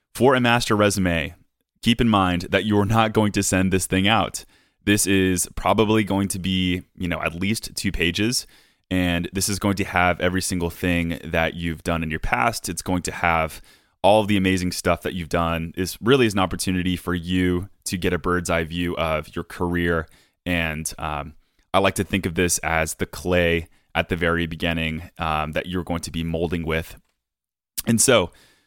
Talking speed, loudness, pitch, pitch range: 200 wpm, -22 LUFS, 90 Hz, 85-95 Hz